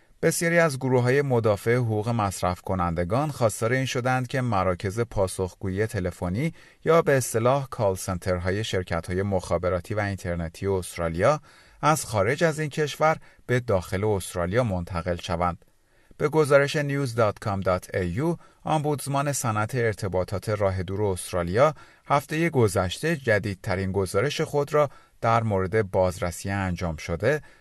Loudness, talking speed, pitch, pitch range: -25 LUFS, 125 wpm, 105 Hz, 95-140 Hz